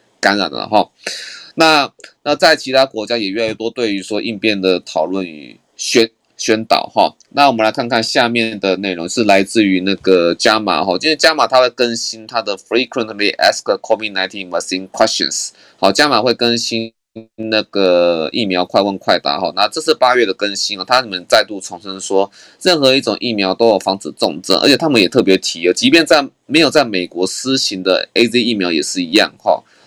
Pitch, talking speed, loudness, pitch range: 110 Hz, 330 characters per minute, -14 LUFS, 95-120 Hz